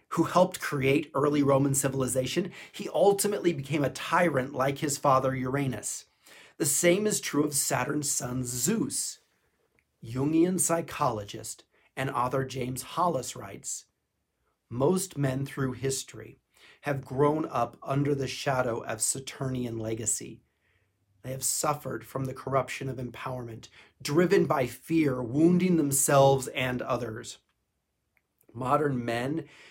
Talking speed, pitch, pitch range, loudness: 120 wpm, 135 Hz, 125-150 Hz, -28 LUFS